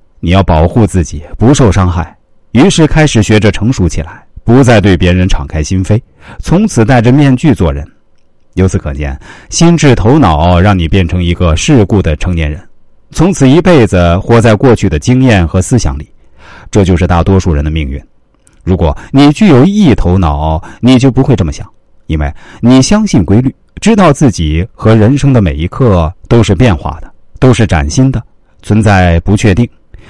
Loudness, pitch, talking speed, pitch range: -8 LUFS, 100 Hz, 260 characters per minute, 85-125 Hz